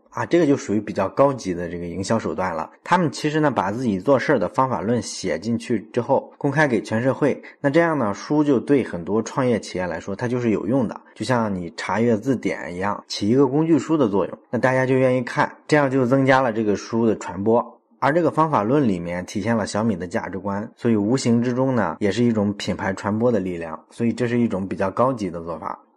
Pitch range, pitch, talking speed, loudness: 100-130 Hz, 115 Hz, 345 characters per minute, -21 LUFS